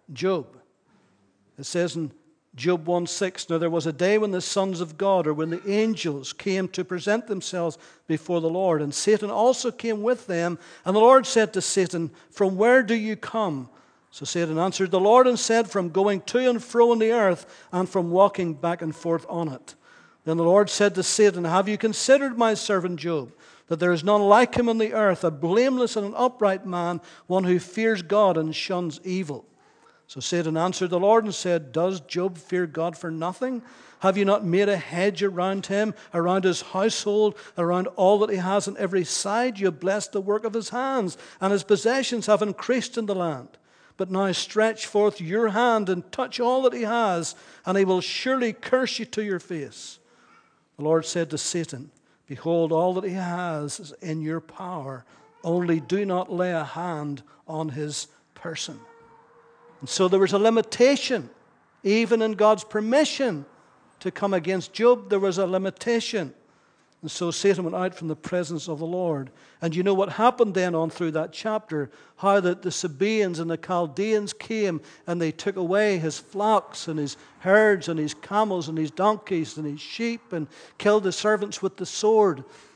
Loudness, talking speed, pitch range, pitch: -24 LUFS, 195 wpm, 170-215 Hz, 190 Hz